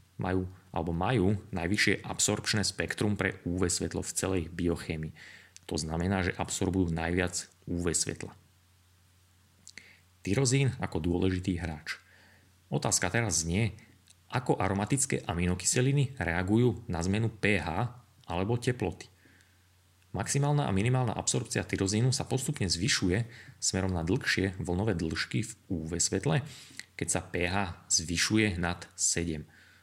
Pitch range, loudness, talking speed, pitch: 90-110 Hz, -30 LUFS, 115 wpm, 95 Hz